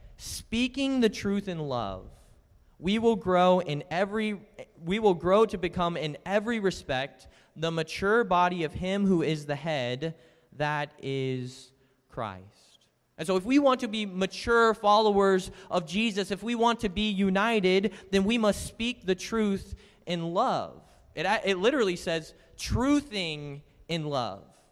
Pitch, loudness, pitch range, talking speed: 190 Hz, -28 LUFS, 155-210 Hz, 150 wpm